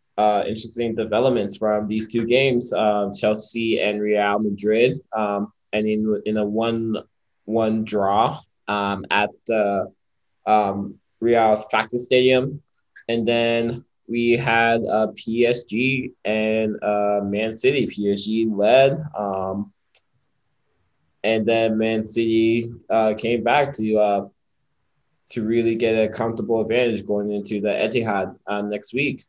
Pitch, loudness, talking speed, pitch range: 110 Hz, -21 LUFS, 130 wpm, 105-115 Hz